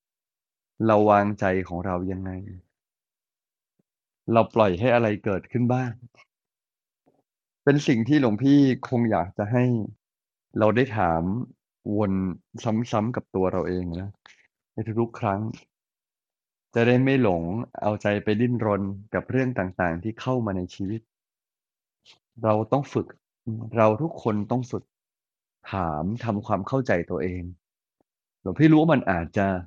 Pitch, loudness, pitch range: 110 Hz, -24 LUFS, 95-120 Hz